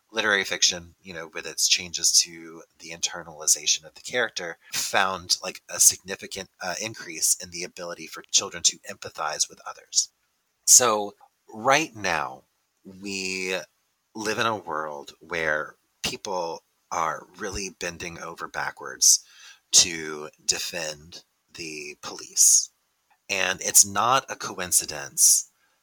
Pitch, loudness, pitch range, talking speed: 85 Hz, -22 LUFS, 80-95 Hz, 120 wpm